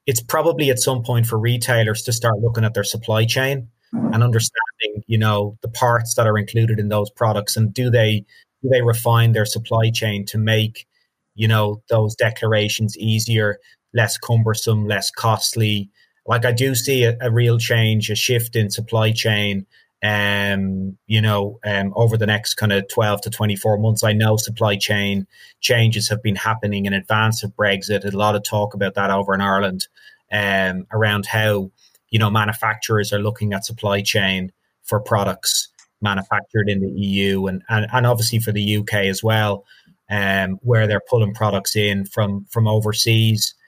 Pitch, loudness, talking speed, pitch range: 110 Hz, -19 LUFS, 175 wpm, 100-115 Hz